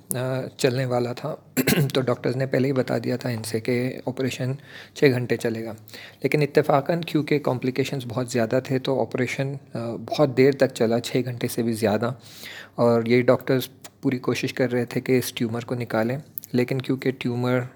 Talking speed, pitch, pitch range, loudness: 180 wpm, 130 Hz, 120-135 Hz, -24 LUFS